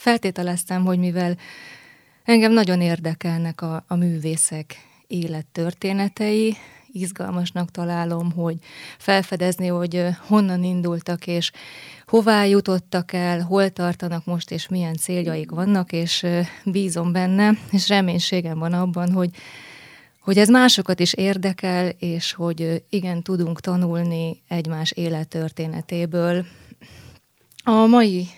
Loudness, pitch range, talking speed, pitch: -21 LUFS, 170-190 Hz, 105 wpm, 175 Hz